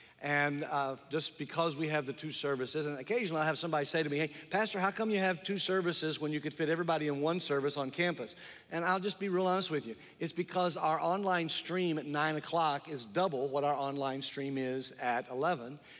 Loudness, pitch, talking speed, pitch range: -34 LUFS, 155 Hz, 225 wpm, 145-175 Hz